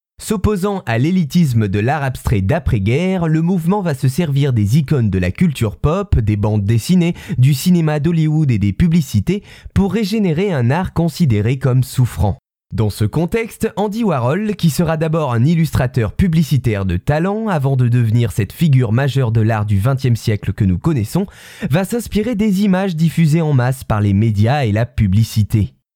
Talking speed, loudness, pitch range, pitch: 170 wpm, -16 LUFS, 115-175 Hz, 140 Hz